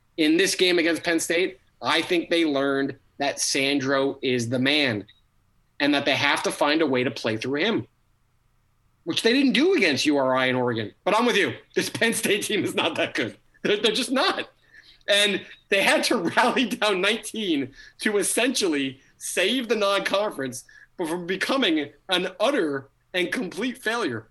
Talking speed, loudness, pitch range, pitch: 175 wpm, -23 LUFS, 130-215 Hz, 170 Hz